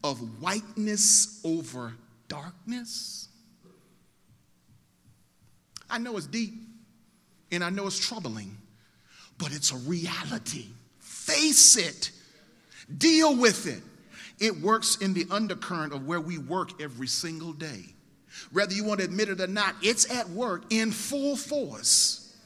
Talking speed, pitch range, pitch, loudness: 130 wpm, 165-225 Hz, 200 Hz, -25 LUFS